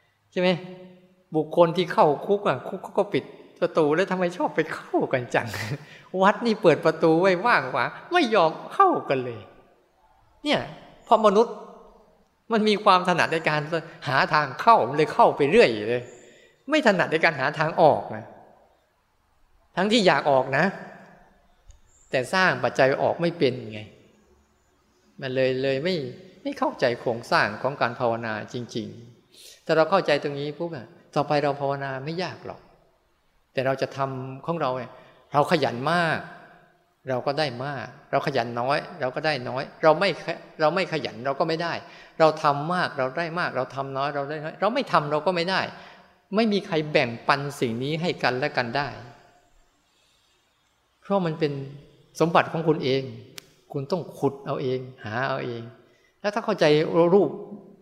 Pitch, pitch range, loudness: 155 Hz, 130-180 Hz, -24 LUFS